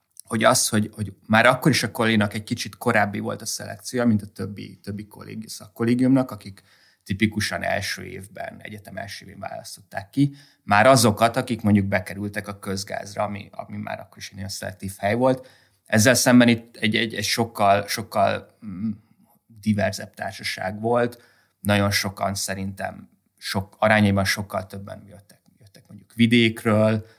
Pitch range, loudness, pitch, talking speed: 100-115 Hz, -22 LUFS, 105 Hz, 150 wpm